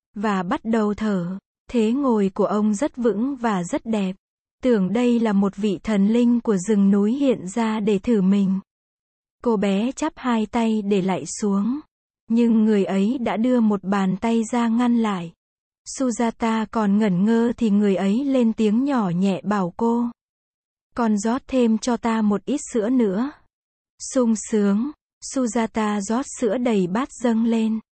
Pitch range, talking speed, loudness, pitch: 205-240 Hz, 165 wpm, -21 LUFS, 225 Hz